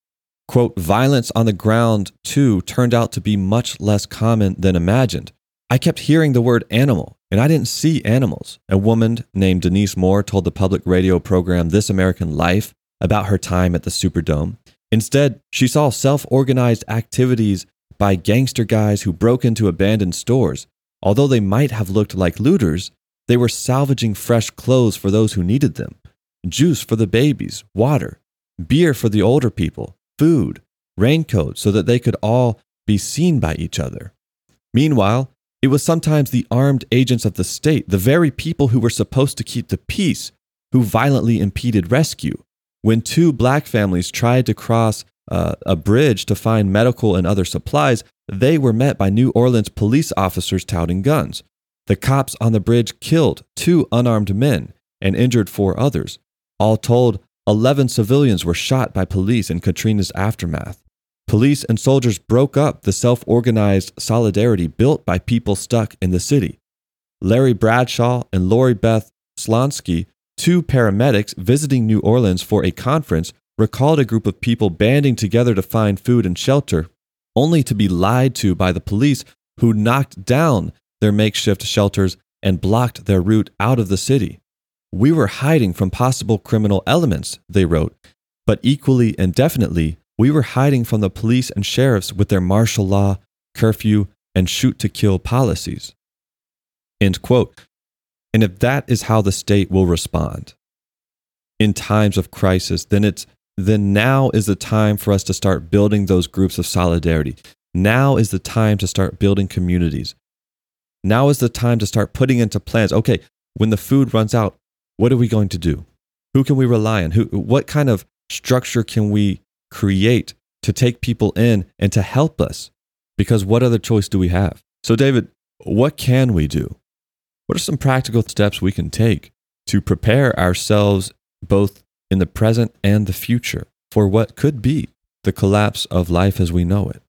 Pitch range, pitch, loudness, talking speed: 95-125 Hz, 110 Hz, -17 LUFS, 170 wpm